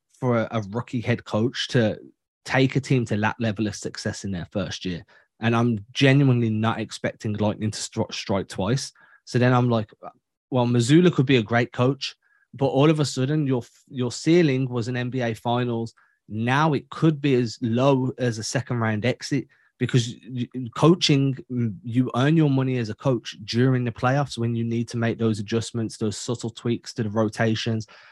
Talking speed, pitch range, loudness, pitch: 185 wpm, 115-130 Hz, -23 LUFS, 120 Hz